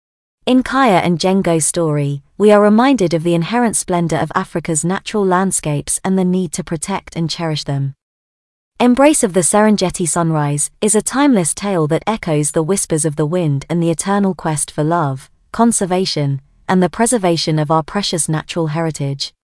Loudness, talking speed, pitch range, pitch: -15 LUFS, 170 wpm, 155-195 Hz, 175 Hz